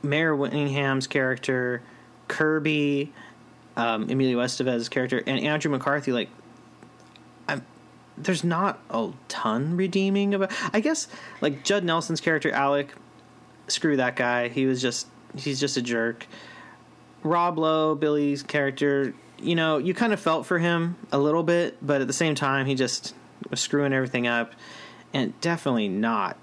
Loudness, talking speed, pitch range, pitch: -25 LUFS, 150 wpm, 130-165 Hz, 145 Hz